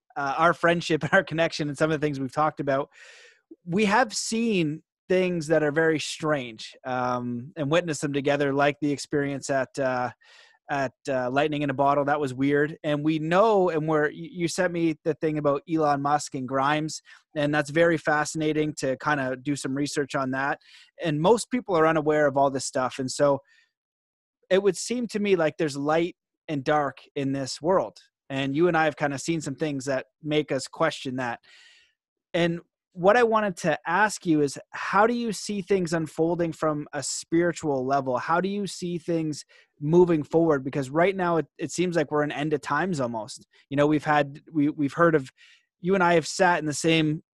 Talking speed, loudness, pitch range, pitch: 205 wpm, -25 LUFS, 145-170 Hz, 155 Hz